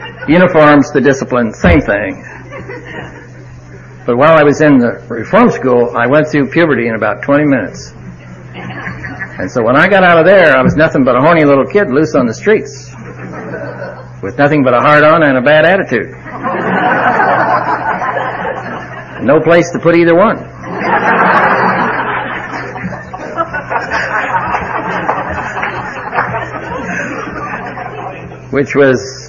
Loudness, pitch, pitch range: -10 LUFS, 135 Hz, 115-150 Hz